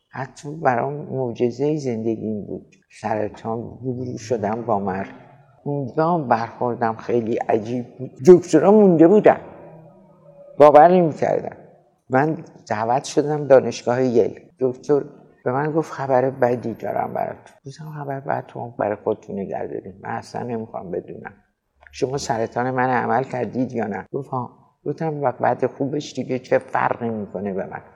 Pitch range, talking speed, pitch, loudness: 120-150 Hz, 130 wpm, 130 Hz, -20 LUFS